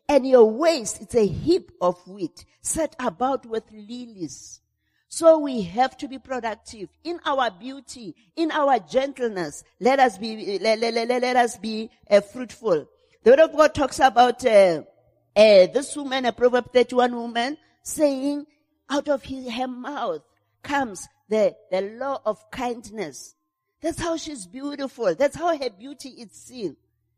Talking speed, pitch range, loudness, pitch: 155 wpm, 220-285 Hz, -22 LUFS, 250 Hz